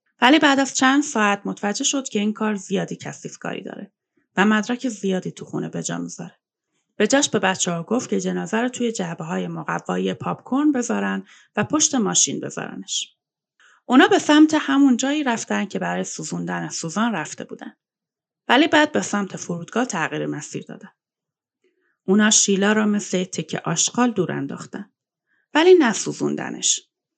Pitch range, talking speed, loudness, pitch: 170-260 Hz, 155 wpm, -20 LUFS, 210 Hz